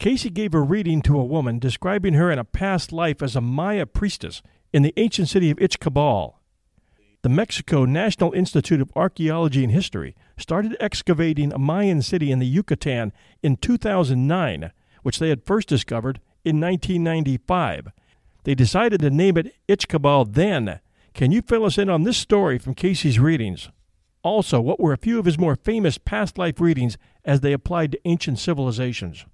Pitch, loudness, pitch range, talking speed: 155 Hz, -21 LUFS, 130-185 Hz, 170 wpm